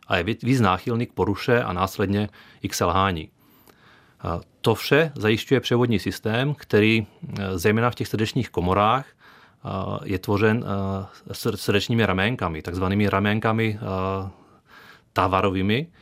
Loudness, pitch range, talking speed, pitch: -23 LUFS, 95-115 Hz, 105 wpm, 105 Hz